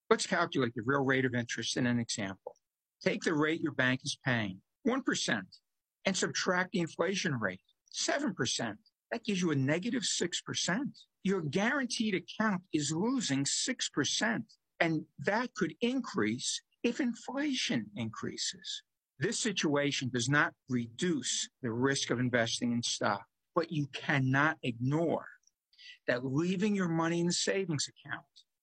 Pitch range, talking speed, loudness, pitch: 130-200 Hz, 140 wpm, -33 LUFS, 160 Hz